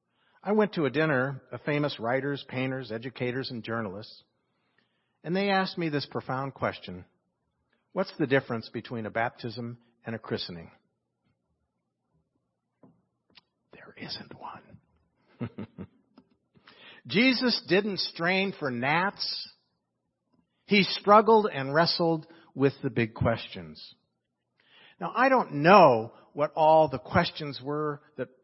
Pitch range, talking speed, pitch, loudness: 120-175 Hz, 115 wpm, 145 Hz, -26 LUFS